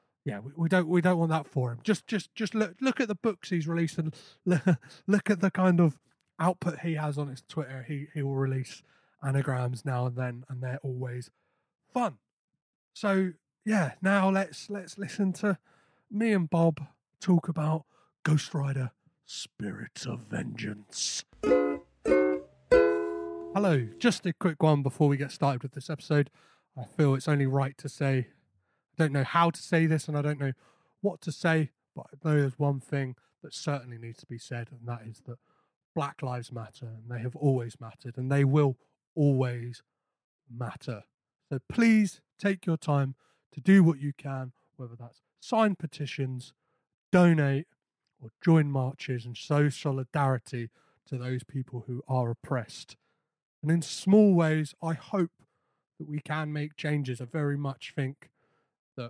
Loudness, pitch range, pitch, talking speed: -29 LUFS, 130-165 Hz, 145 Hz, 170 wpm